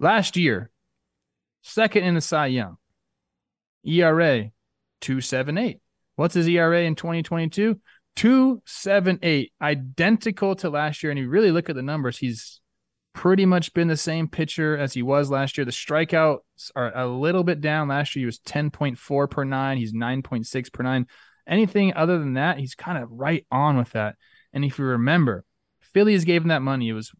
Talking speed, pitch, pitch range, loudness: 170 wpm, 150 Hz, 125-170 Hz, -23 LUFS